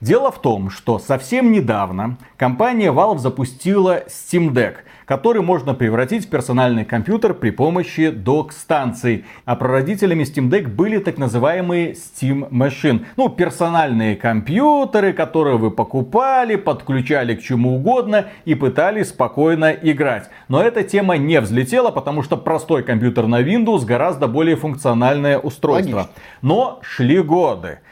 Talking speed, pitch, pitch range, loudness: 130 wpm, 150 Hz, 125-185 Hz, -17 LUFS